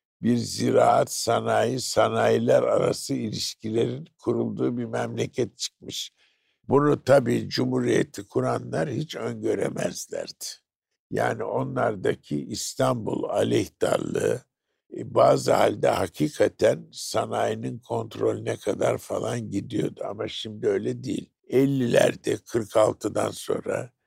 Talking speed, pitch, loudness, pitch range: 85 wpm, 100 Hz, -25 LUFS, 70-120 Hz